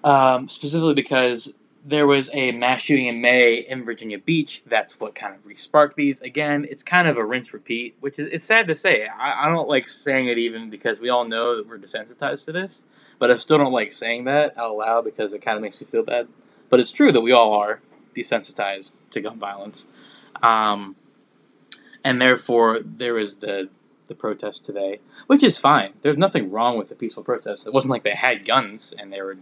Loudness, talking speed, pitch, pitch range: -20 LUFS, 215 wpm, 125 Hz, 115-145 Hz